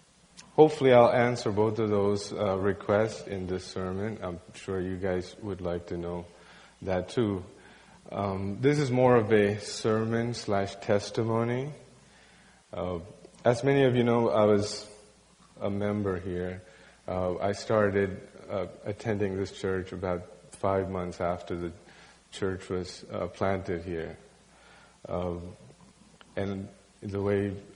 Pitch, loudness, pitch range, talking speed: 100 Hz, -29 LUFS, 90-110 Hz, 135 wpm